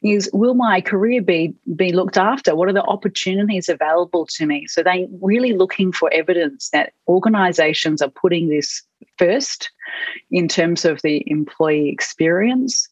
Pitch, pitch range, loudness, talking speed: 180 Hz, 160-200 Hz, -18 LUFS, 155 wpm